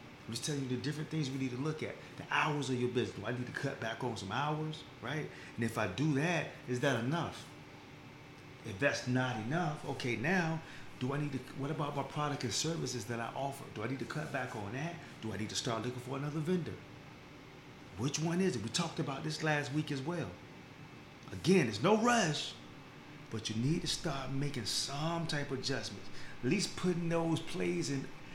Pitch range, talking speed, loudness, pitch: 125-155 Hz, 220 wpm, -36 LUFS, 140 Hz